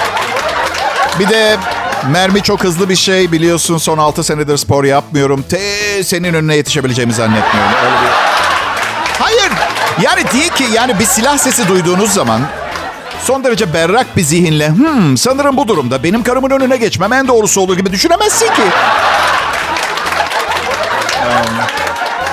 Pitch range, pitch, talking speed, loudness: 155-230 Hz, 190 Hz, 135 wpm, -11 LUFS